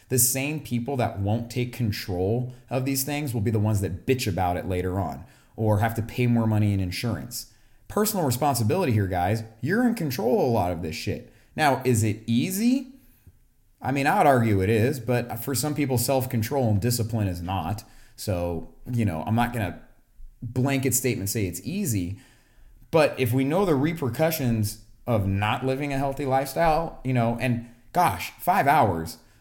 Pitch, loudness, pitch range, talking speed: 120 Hz, -25 LUFS, 105-130 Hz, 185 wpm